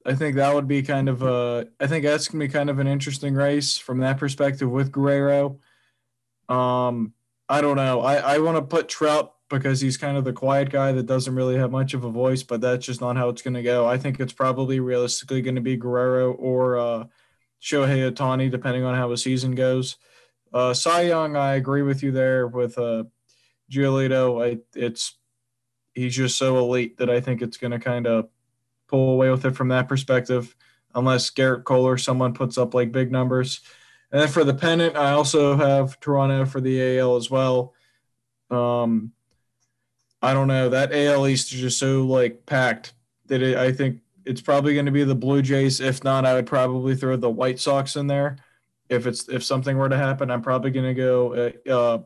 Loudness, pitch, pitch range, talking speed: -22 LUFS, 130 Hz, 125-135 Hz, 200 wpm